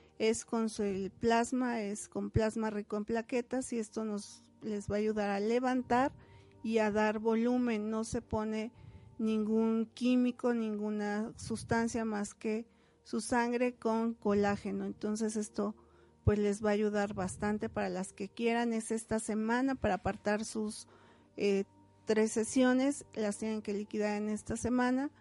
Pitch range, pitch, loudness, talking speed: 210-230 Hz, 220 Hz, -34 LUFS, 155 wpm